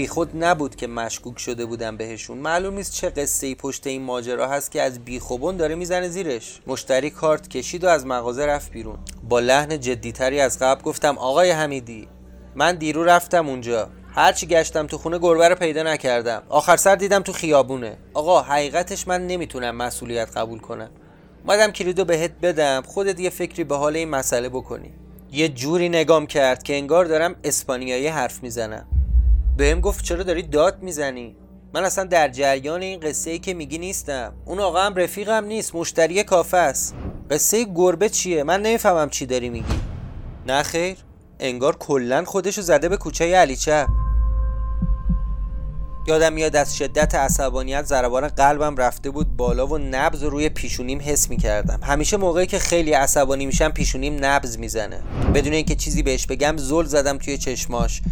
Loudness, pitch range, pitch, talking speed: -21 LUFS, 125-170 Hz, 145 Hz, 165 wpm